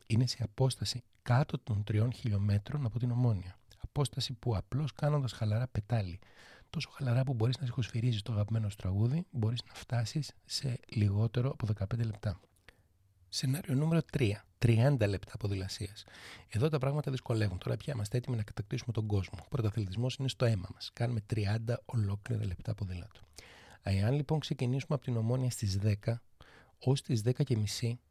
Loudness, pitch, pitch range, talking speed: -34 LUFS, 115 Hz, 105-130 Hz, 155 wpm